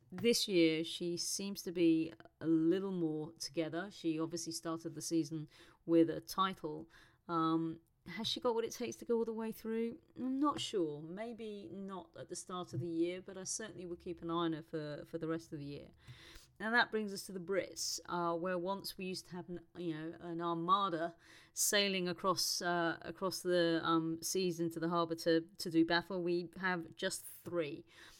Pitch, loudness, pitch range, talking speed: 170 Hz, -37 LUFS, 165-190 Hz, 200 wpm